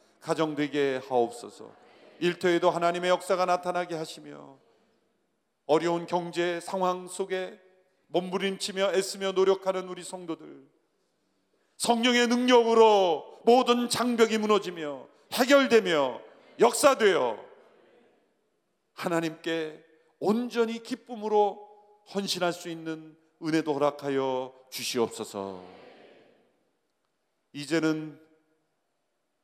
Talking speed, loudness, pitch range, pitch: 220 characters per minute, -27 LUFS, 160-210 Hz, 180 Hz